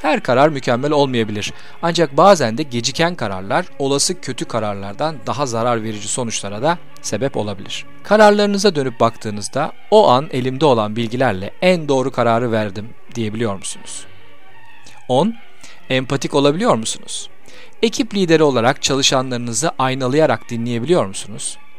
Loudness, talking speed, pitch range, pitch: -17 LUFS, 120 wpm, 115-155 Hz, 130 Hz